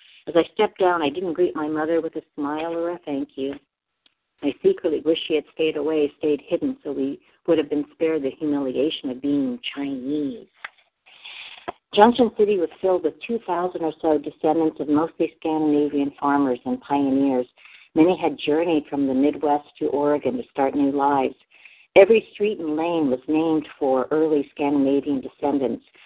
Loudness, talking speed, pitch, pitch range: -22 LUFS, 170 wpm, 155 Hz, 140-165 Hz